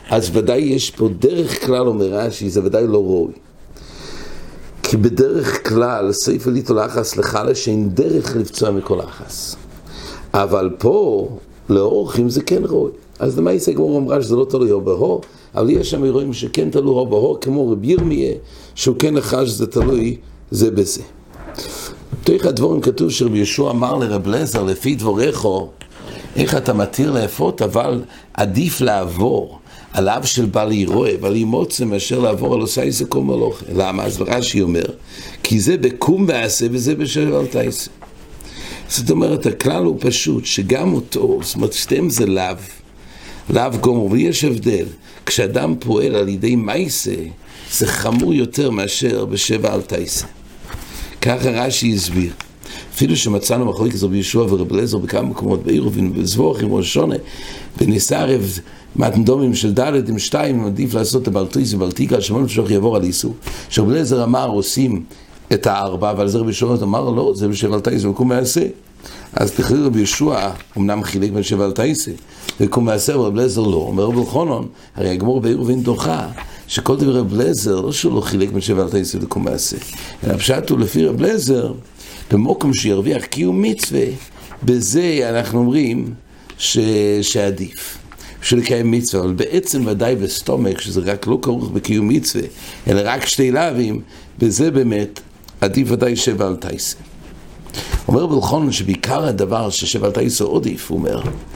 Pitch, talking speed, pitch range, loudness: 115 Hz, 155 wpm, 100-130 Hz, -17 LUFS